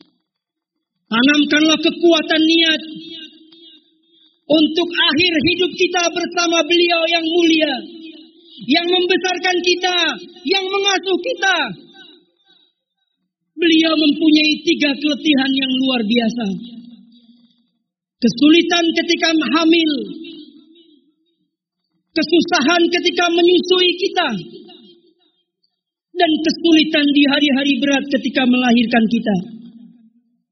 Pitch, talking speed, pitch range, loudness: 315 Hz, 75 wpm, 265-340 Hz, -15 LUFS